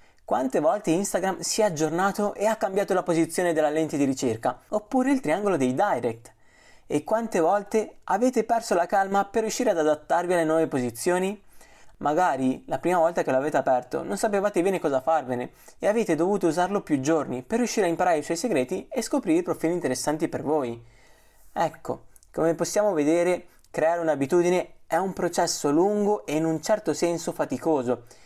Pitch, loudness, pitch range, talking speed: 170 Hz, -25 LUFS, 155-205 Hz, 175 wpm